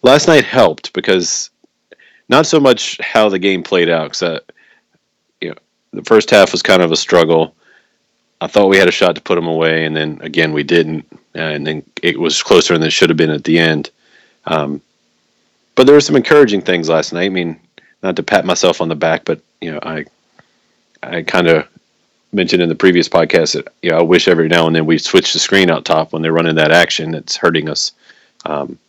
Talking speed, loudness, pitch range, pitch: 220 wpm, -12 LUFS, 80-85 Hz, 80 Hz